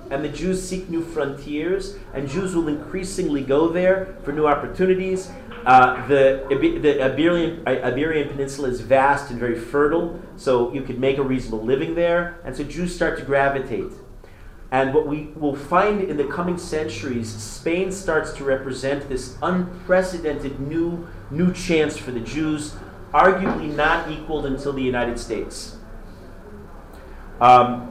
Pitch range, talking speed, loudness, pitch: 125-170 Hz, 150 wpm, -21 LUFS, 145 Hz